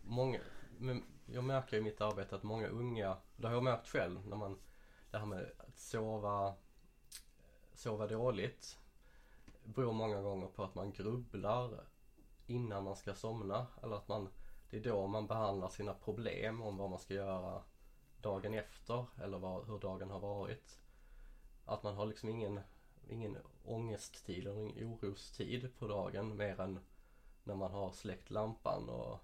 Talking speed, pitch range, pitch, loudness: 155 wpm, 100-115 Hz, 105 Hz, -43 LUFS